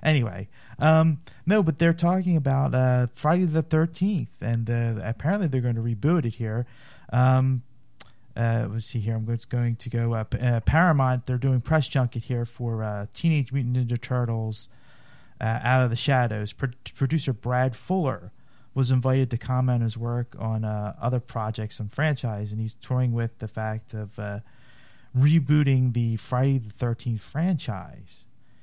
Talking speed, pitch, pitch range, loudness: 165 wpm, 125 Hz, 115-135 Hz, -25 LUFS